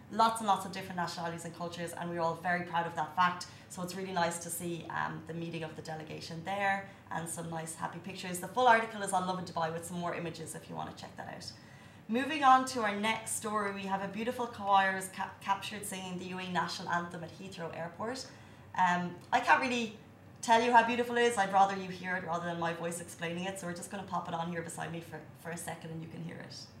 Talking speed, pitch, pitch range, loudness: 255 wpm, 175 Hz, 165-195 Hz, -33 LUFS